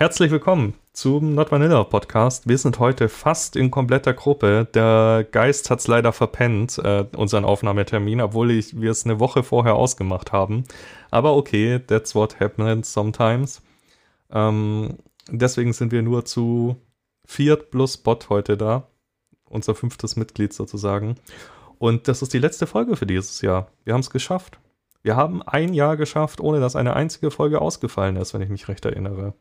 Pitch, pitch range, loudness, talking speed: 115 Hz, 105-135 Hz, -20 LUFS, 160 wpm